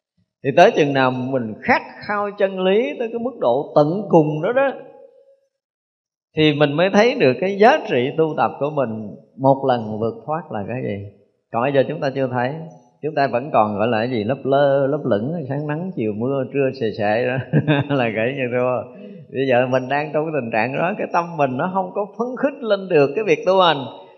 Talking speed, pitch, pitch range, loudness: 225 wpm, 145 Hz, 125-185 Hz, -19 LUFS